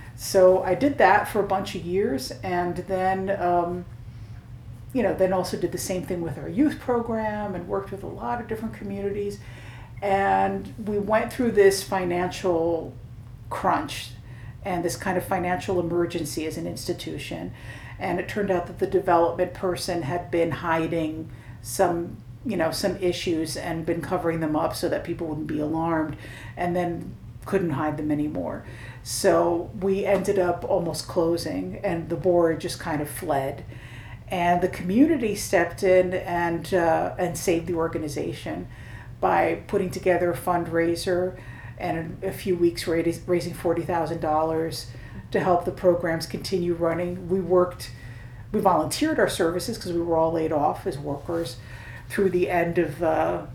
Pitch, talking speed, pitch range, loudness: 170 Hz, 160 wpm, 150-185 Hz, -25 LUFS